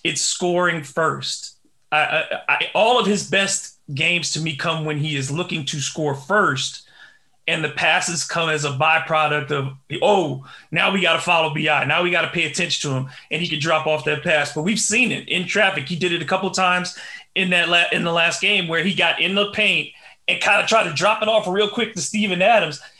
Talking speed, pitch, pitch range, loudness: 235 wpm, 170 Hz, 155-190 Hz, -19 LUFS